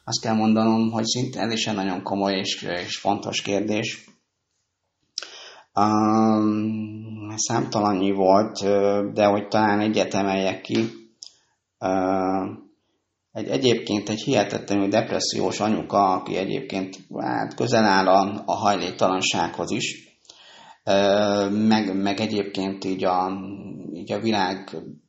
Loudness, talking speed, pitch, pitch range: -23 LUFS, 110 wpm, 100 Hz, 95-110 Hz